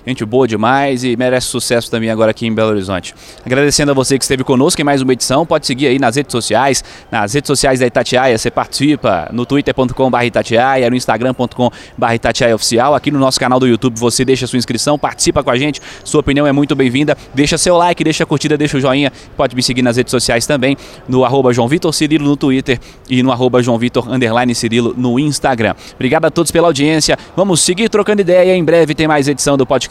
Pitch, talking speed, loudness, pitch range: 130 Hz, 215 wpm, -13 LUFS, 120-145 Hz